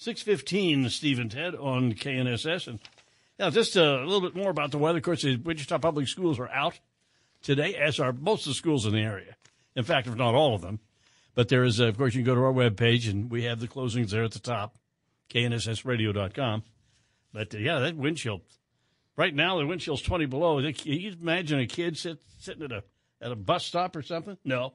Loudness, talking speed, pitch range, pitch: -28 LUFS, 220 wpm, 115-160 Hz, 130 Hz